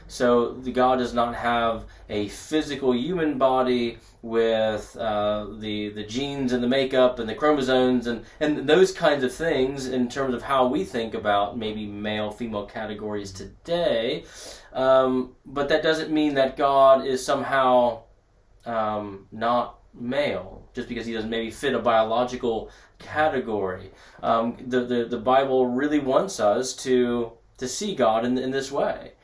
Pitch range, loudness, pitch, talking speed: 110-130 Hz, -24 LUFS, 120 Hz, 155 wpm